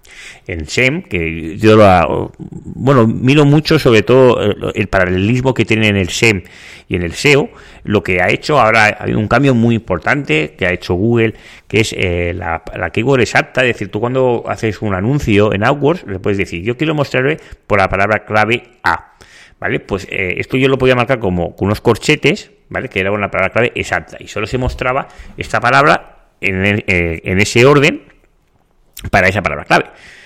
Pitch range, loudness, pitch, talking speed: 95-130 Hz, -13 LUFS, 105 Hz, 195 wpm